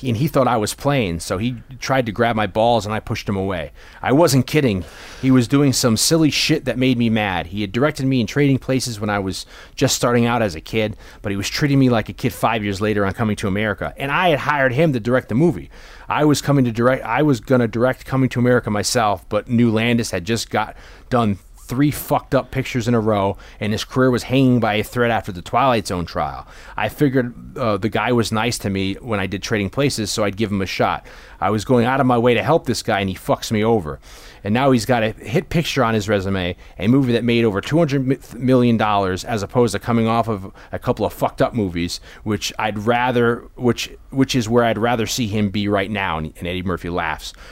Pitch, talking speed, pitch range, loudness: 115 Hz, 245 wpm, 100-130 Hz, -19 LUFS